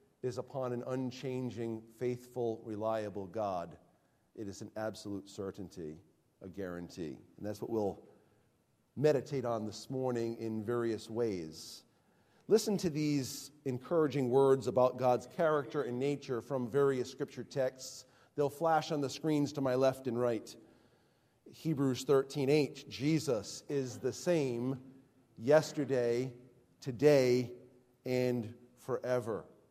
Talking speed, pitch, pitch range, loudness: 120 wpm, 125 Hz, 115-140 Hz, -35 LUFS